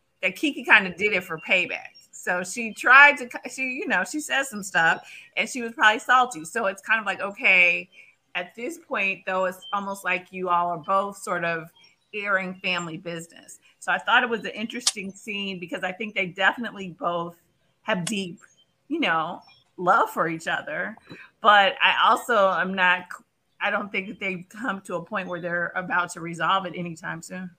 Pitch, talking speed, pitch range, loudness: 195 Hz, 195 wpm, 175-220 Hz, -23 LUFS